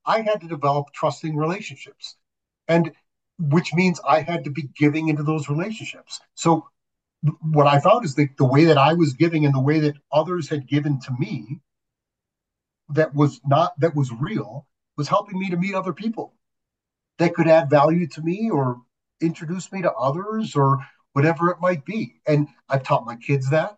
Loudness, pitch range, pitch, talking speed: -21 LUFS, 145-170 Hz, 155 Hz, 185 wpm